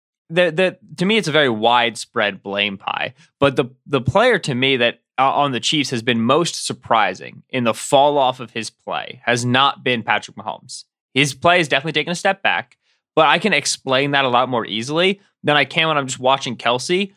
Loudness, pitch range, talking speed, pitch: -18 LUFS, 120-165 Hz, 215 wpm, 135 Hz